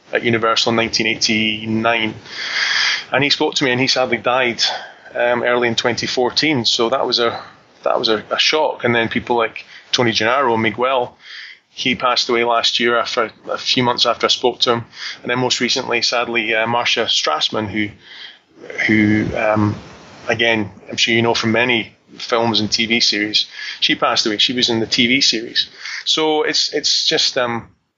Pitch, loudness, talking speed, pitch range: 115 Hz, -16 LUFS, 180 wpm, 110-120 Hz